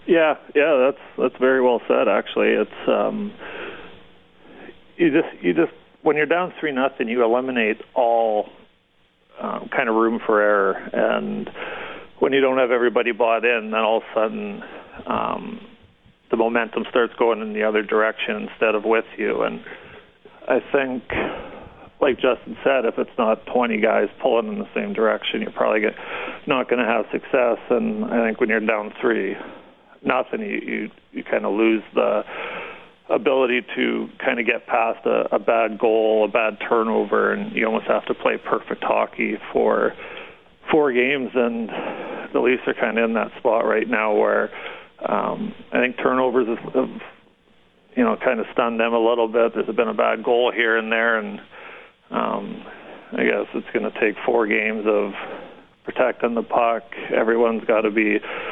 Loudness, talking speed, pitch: -21 LUFS, 170 wpm, 120 Hz